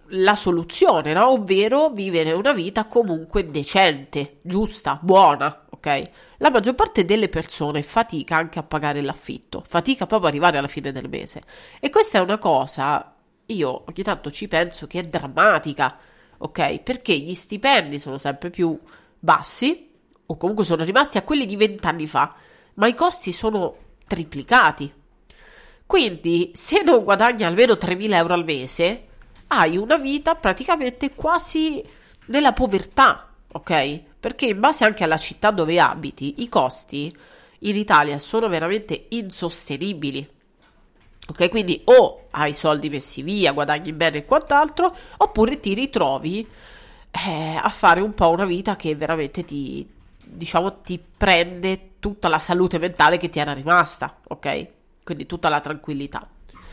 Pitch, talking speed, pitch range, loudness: 180 Hz, 145 wpm, 155-220 Hz, -20 LUFS